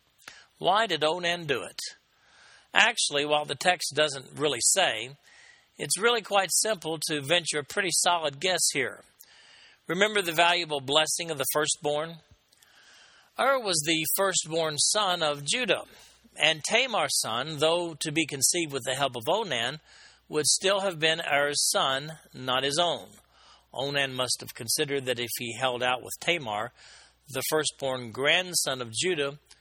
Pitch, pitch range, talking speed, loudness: 155 Hz, 140-175 Hz, 150 wpm, -26 LUFS